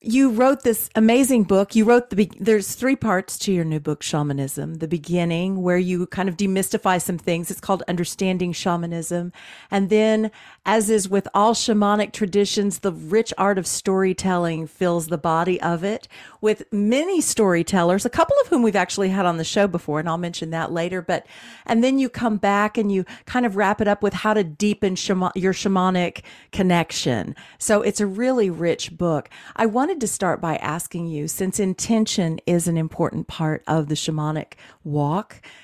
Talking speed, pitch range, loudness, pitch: 185 wpm, 170-215 Hz, -21 LUFS, 190 Hz